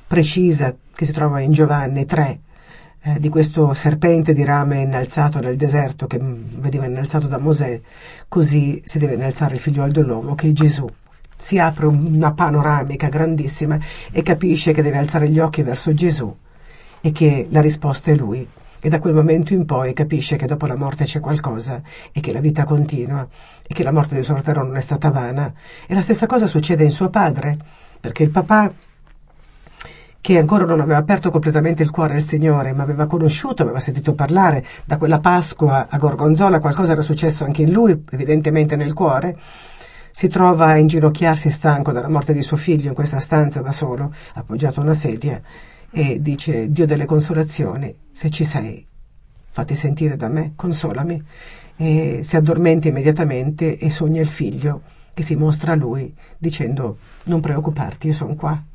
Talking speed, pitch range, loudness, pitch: 175 wpm, 145-160 Hz, -17 LUFS, 150 Hz